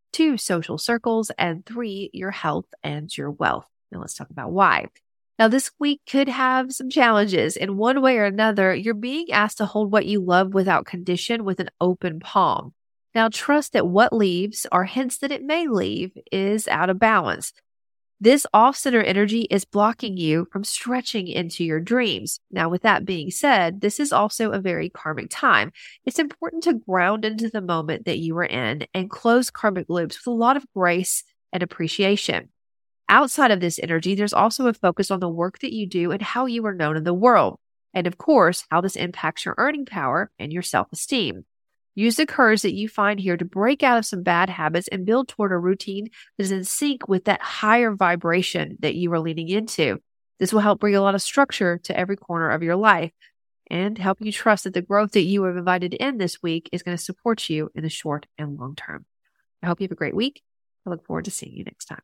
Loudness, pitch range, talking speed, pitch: -21 LUFS, 175-230 Hz, 215 wpm, 200 Hz